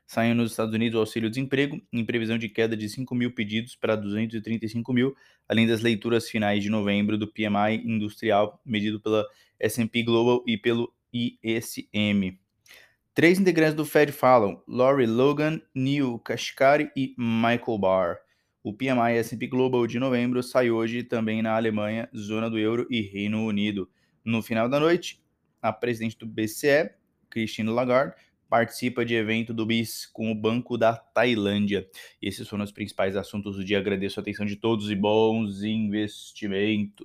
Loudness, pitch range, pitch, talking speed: -25 LUFS, 105-120 Hz, 115 Hz, 160 wpm